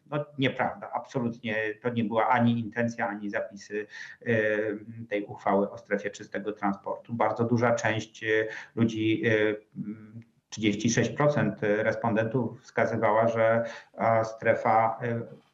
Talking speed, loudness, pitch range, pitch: 95 wpm, -28 LUFS, 110-120 Hz, 115 Hz